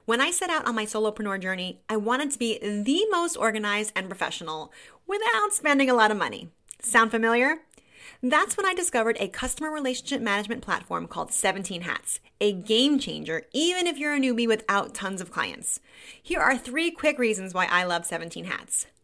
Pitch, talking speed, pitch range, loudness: 230 Hz, 185 wpm, 200-295 Hz, -25 LUFS